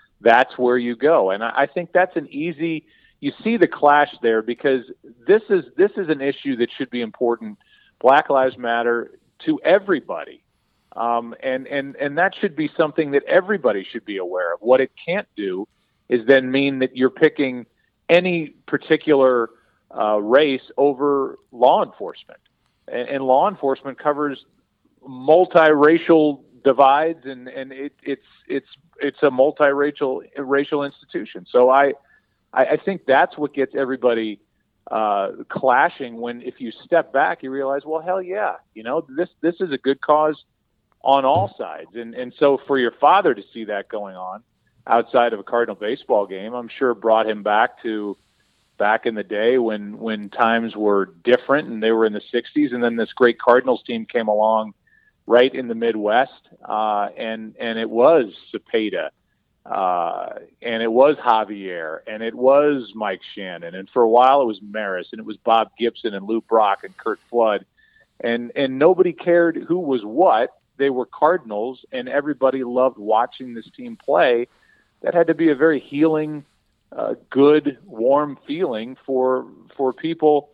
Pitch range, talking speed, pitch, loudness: 115-150 Hz, 170 wpm, 135 Hz, -19 LUFS